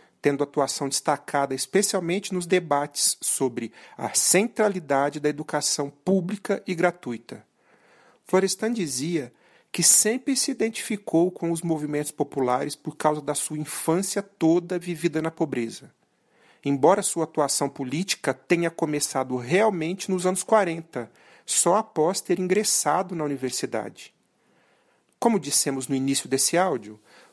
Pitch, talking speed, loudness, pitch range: 160 Hz, 120 wpm, -24 LUFS, 145-185 Hz